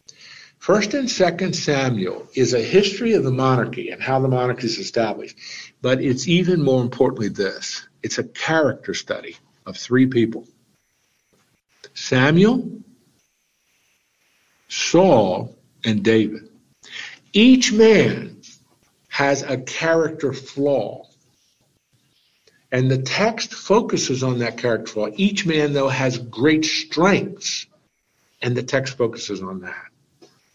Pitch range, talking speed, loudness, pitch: 125-185 Hz, 115 wpm, -19 LUFS, 135 Hz